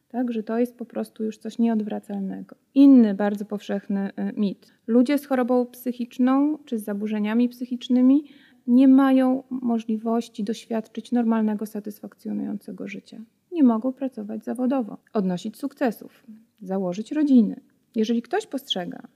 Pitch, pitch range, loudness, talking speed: 235 Hz, 215-255 Hz, -23 LUFS, 120 wpm